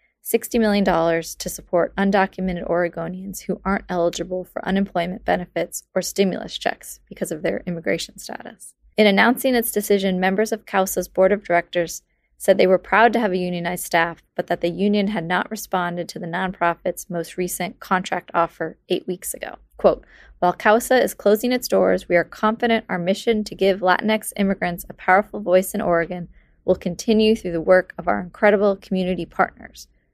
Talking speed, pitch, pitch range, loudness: 175 wpm, 185 Hz, 175-205 Hz, -21 LUFS